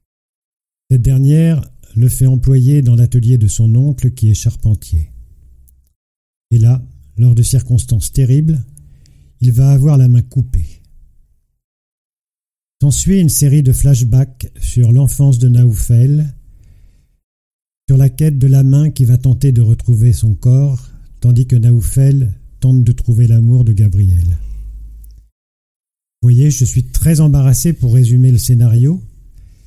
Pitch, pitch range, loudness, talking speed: 120 Hz, 100-135 Hz, -11 LUFS, 135 wpm